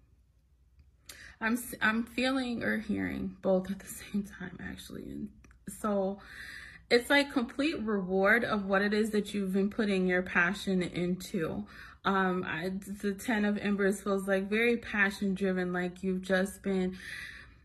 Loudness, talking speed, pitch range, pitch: -31 LUFS, 145 wpm, 185-215 Hz, 195 Hz